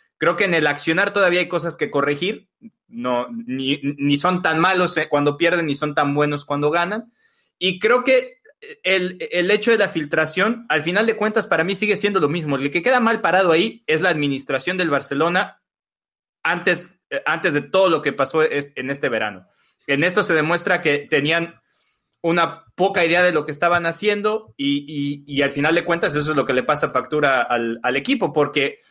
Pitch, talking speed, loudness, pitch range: 165 Hz, 200 wpm, -19 LUFS, 145-190 Hz